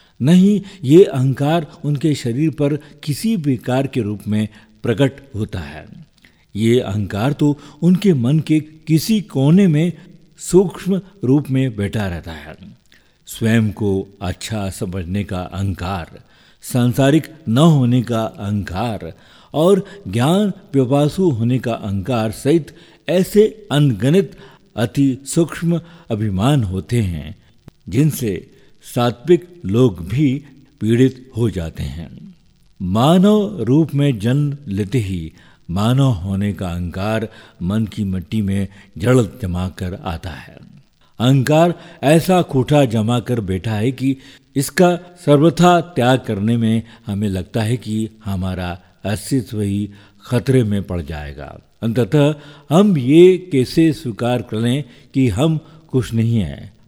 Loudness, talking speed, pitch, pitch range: -17 LUFS, 120 wpm, 125 Hz, 105-150 Hz